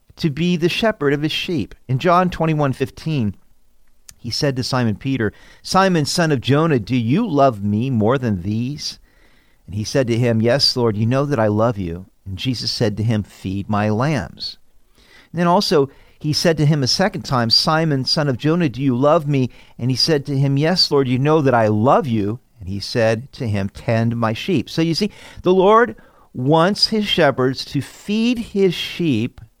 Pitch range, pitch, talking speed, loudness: 115-160 Hz, 135 Hz, 200 wpm, -18 LUFS